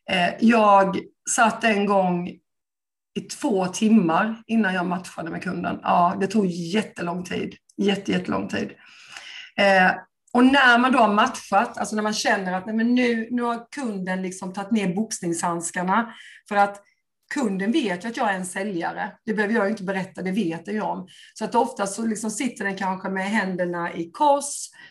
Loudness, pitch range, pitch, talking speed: -23 LUFS, 185-225 Hz, 200 Hz, 170 wpm